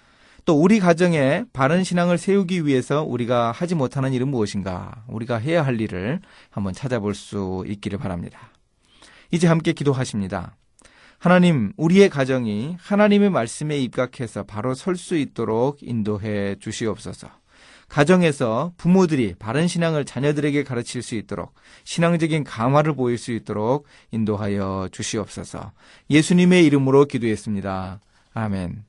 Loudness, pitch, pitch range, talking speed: -21 LUFS, 125 Hz, 105-165 Hz, 330 characters per minute